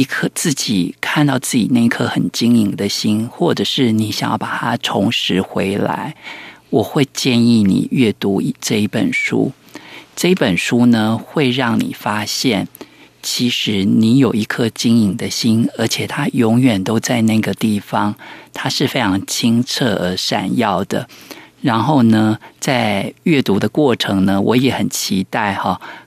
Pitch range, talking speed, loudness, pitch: 105-120 Hz, 220 characters per minute, -16 LUFS, 115 Hz